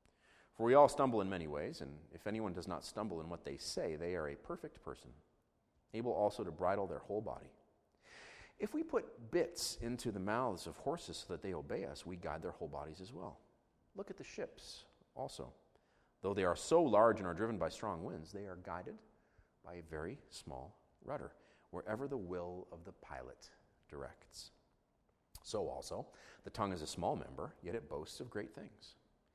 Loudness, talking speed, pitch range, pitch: -40 LUFS, 195 wpm, 85-110 Hz, 90 Hz